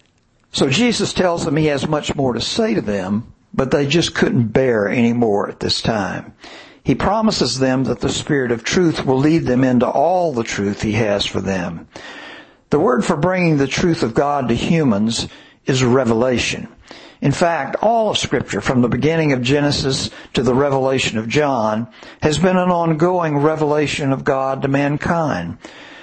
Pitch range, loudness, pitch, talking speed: 125-170 Hz, -17 LUFS, 140 Hz, 180 wpm